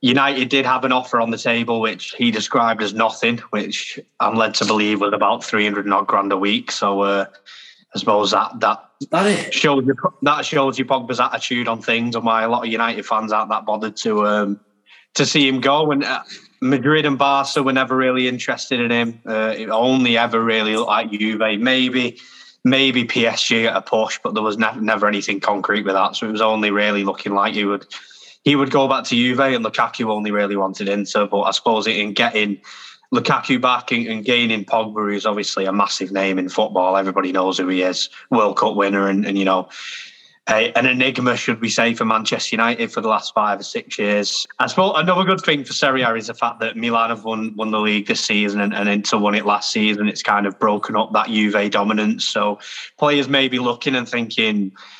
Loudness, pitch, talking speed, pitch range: -18 LUFS, 110 Hz, 220 wpm, 105-125 Hz